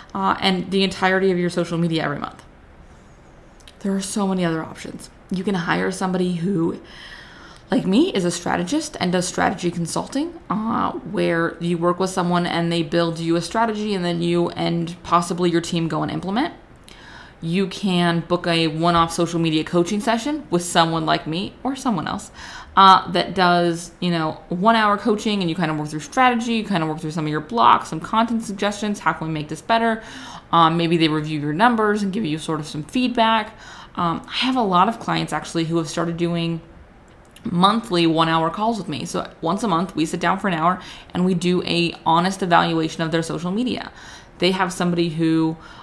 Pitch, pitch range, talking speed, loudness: 175 Hz, 165-200 Hz, 205 wpm, -20 LUFS